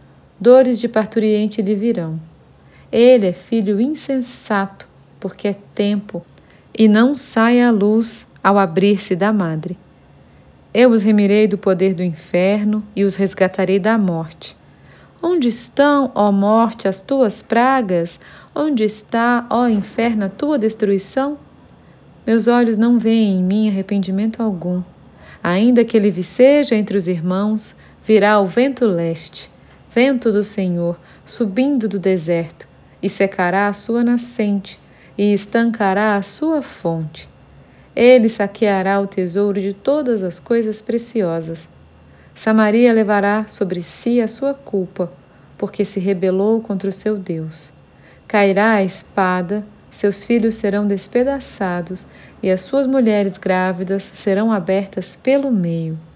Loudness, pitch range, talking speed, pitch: -17 LUFS, 190-230 Hz, 130 wpm, 205 Hz